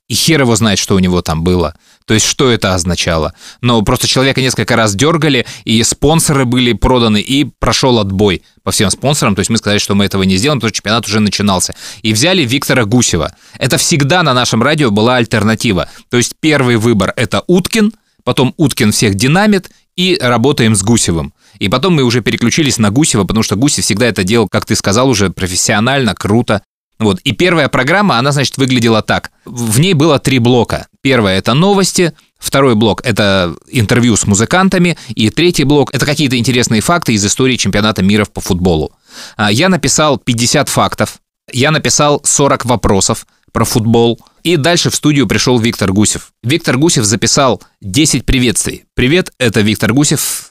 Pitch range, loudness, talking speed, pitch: 105-140 Hz, -11 LUFS, 175 wpm, 120 Hz